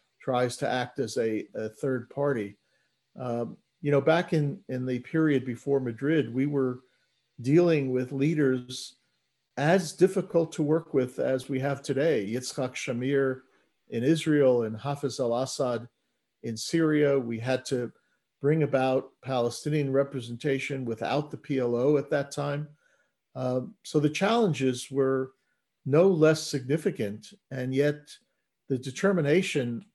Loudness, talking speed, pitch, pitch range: -28 LUFS, 135 wpm, 135 Hz, 125-150 Hz